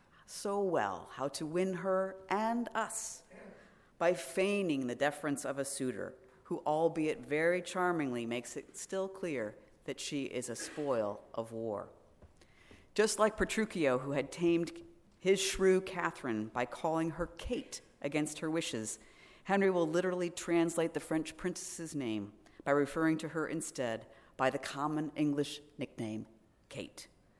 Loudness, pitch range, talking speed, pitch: -35 LUFS, 140-185 Hz, 140 wpm, 165 Hz